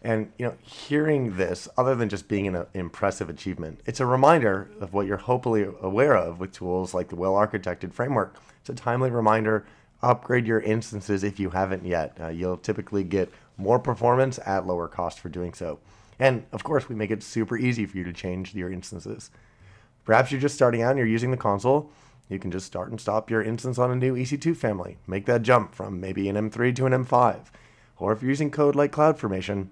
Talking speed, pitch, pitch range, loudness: 210 wpm, 110 Hz, 95-125 Hz, -25 LUFS